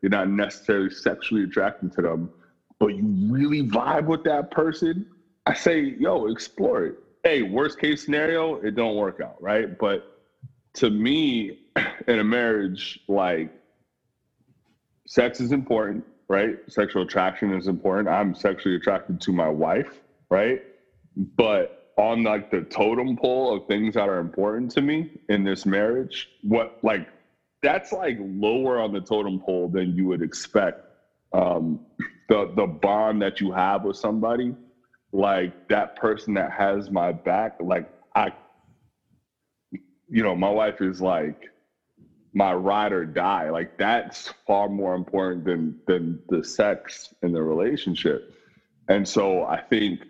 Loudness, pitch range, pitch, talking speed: -24 LUFS, 95-140 Hz, 105 Hz, 145 wpm